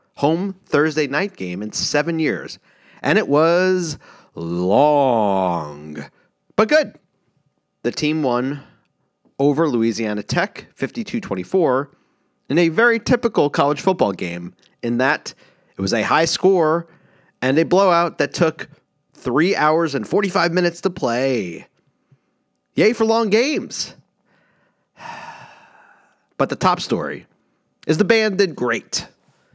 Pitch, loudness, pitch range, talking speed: 155 Hz, -19 LUFS, 125-190 Hz, 120 wpm